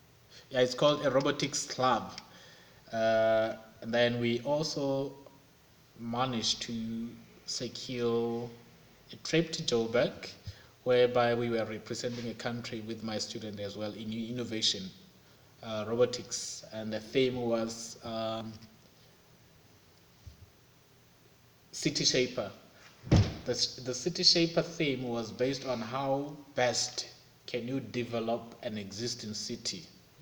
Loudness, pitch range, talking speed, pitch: -32 LUFS, 115-130 Hz, 110 wpm, 120 Hz